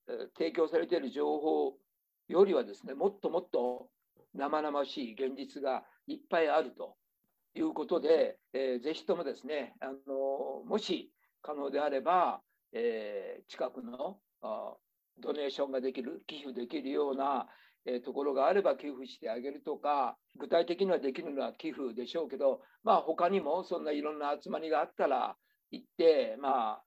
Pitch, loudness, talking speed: 165 Hz, -34 LUFS, 320 characters per minute